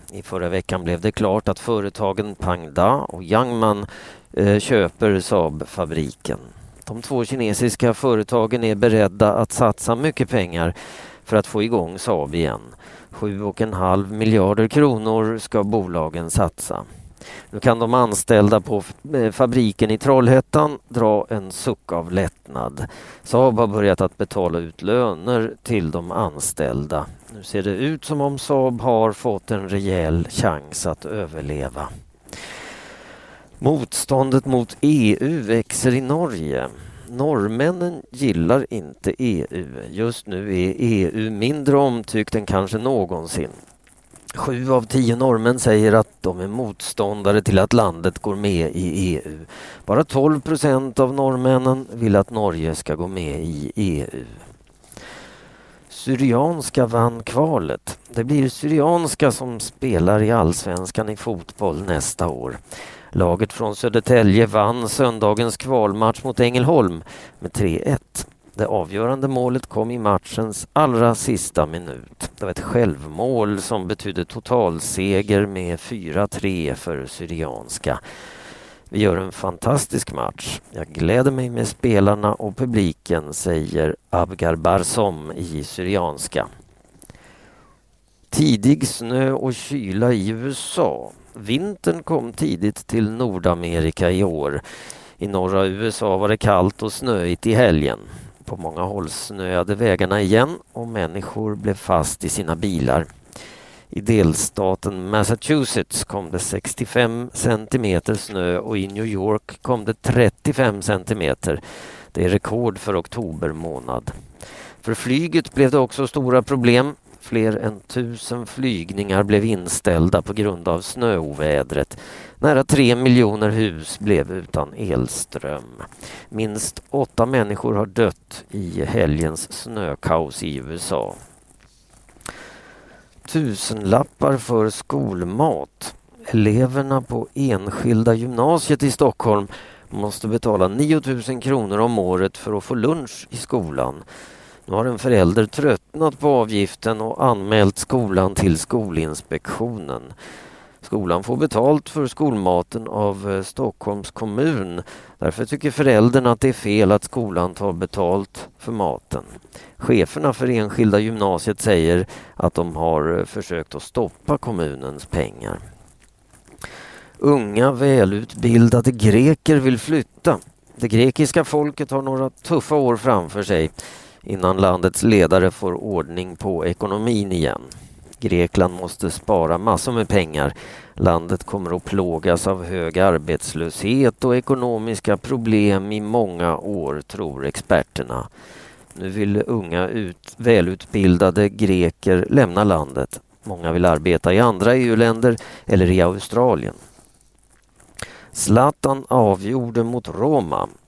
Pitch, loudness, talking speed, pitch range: 105 Hz, -20 LUFS, 120 wpm, 90-125 Hz